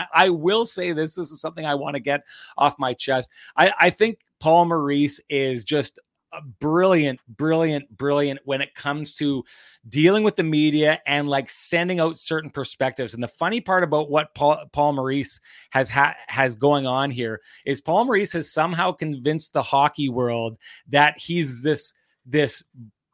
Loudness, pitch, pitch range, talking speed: -22 LUFS, 145 Hz, 135-160 Hz, 175 wpm